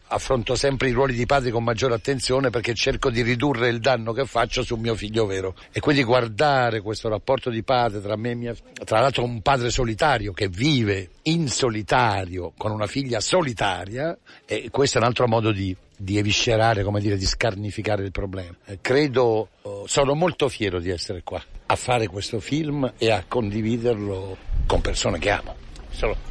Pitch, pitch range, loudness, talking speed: 115 Hz, 105-130 Hz, -23 LUFS, 185 wpm